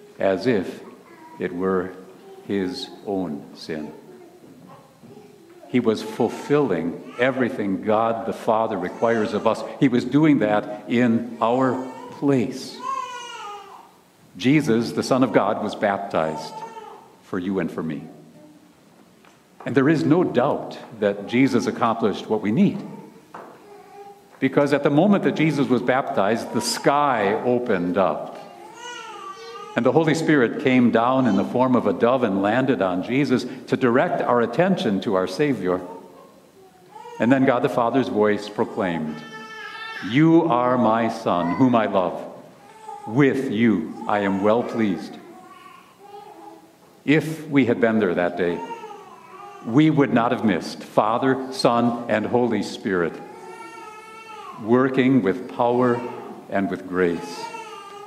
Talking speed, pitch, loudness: 130 wpm, 135 Hz, -21 LUFS